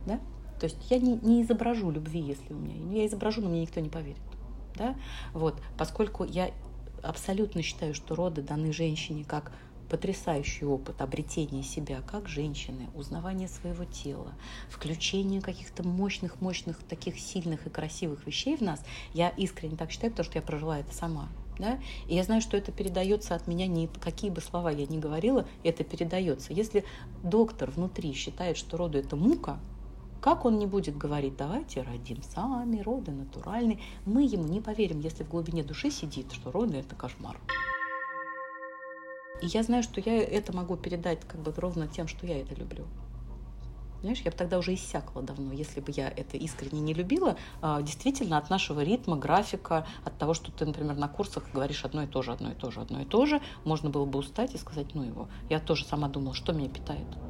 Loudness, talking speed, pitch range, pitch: -32 LUFS, 185 wpm, 145-200 Hz, 165 Hz